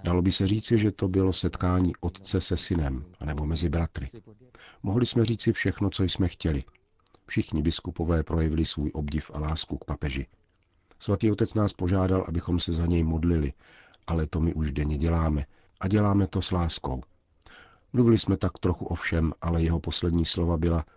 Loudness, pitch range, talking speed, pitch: -27 LUFS, 80-95 Hz, 175 wpm, 85 Hz